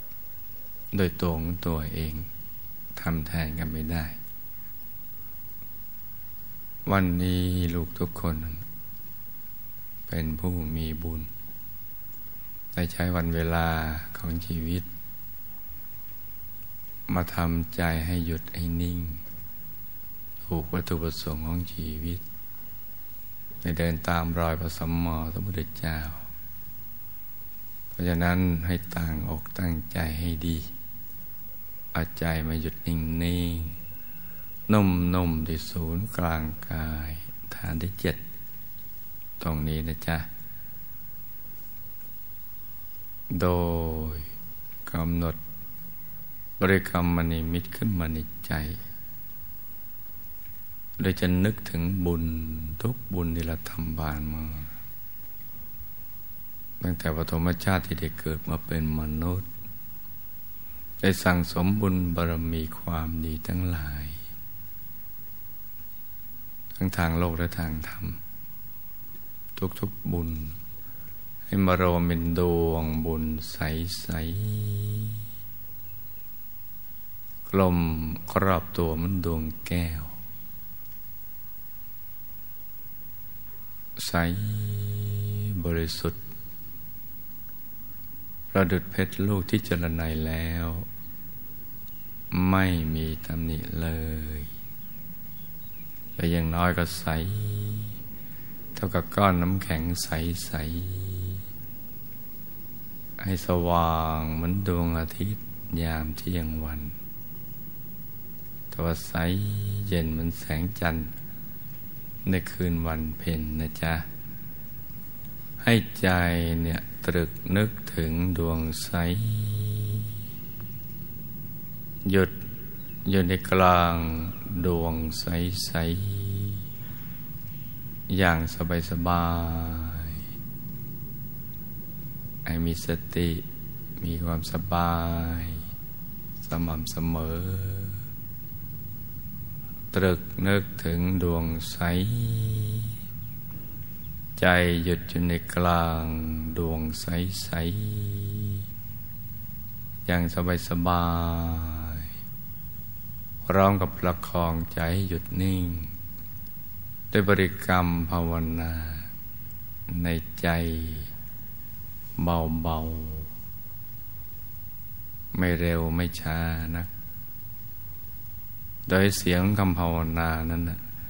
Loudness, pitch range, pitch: -30 LUFS, 80-95 Hz, 85 Hz